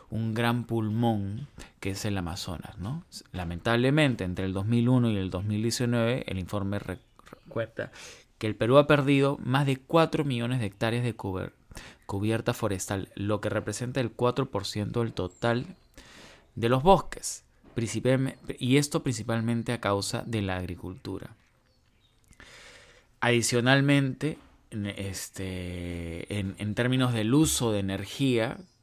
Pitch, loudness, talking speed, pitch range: 115 Hz, -28 LUFS, 125 wpm, 100-125 Hz